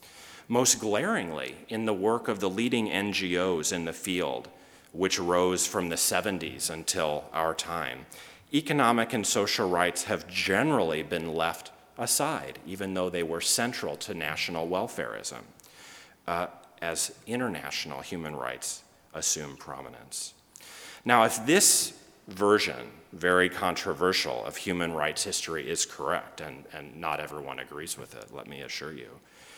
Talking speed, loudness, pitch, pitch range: 135 wpm, -28 LUFS, 90 Hz, 80-105 Hz